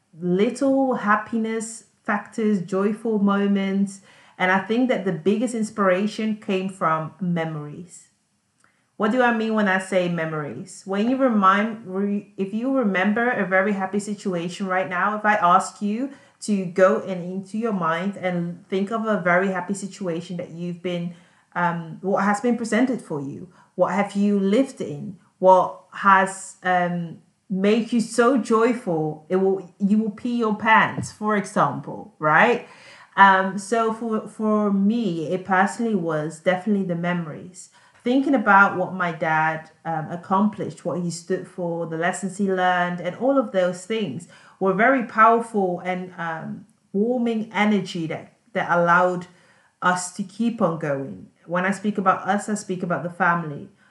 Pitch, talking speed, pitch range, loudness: 195 Hz, 155 wpm, 180-215 Hz, -22 LUFS